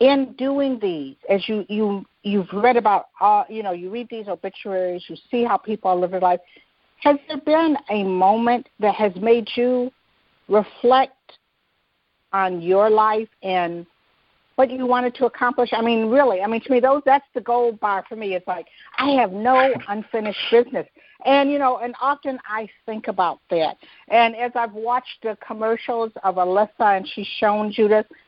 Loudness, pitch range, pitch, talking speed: -20 LUFS, 205-255 Hz, 225 Hz, 180 wpm